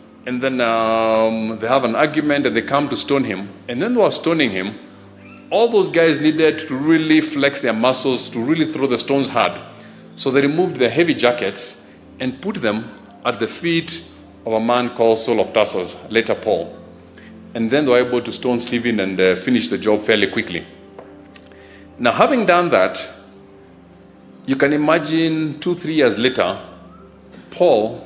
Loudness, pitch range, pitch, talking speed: -18 LUFS, 110-155 Hz, 125 Hz, 175 wpm